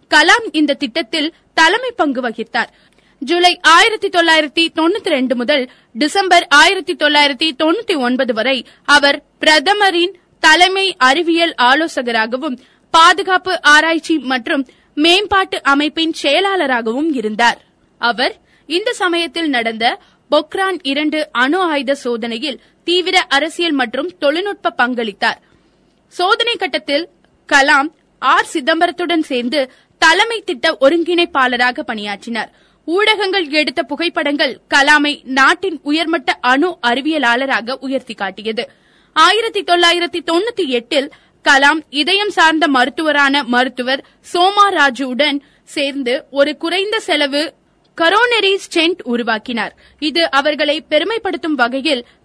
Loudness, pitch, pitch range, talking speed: -14 LUFS, 310 Hz, 270-345 Hz, 100 wpm